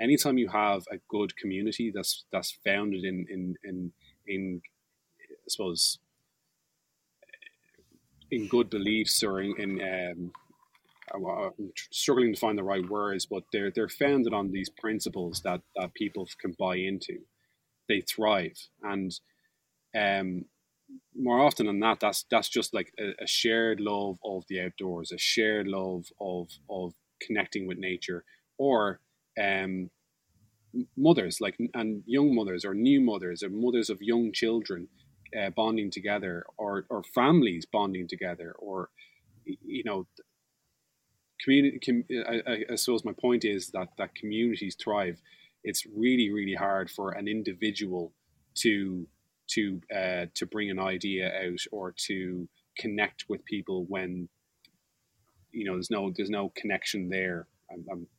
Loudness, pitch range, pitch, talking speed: -30 LUFS, 90-115 Hz, 100 Hz, 140 wpm